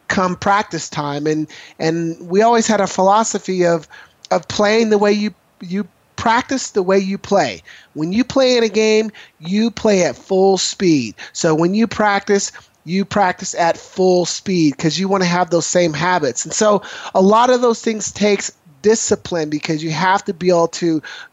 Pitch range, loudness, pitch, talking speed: 170-210 Hz, -16 LUFS, 195 Hz, 185 wpm